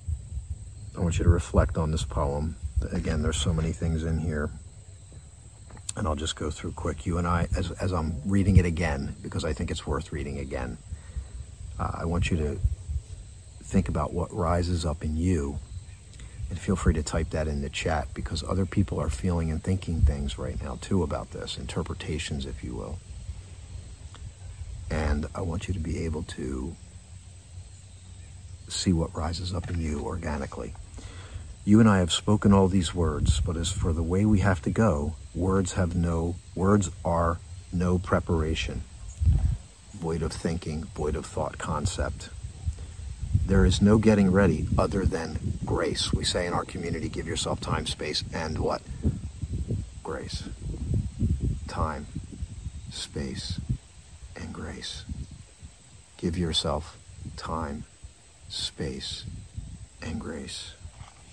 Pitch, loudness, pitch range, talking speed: 90 Hz, -28 LUFS, 80-95 Hz, 150 wpm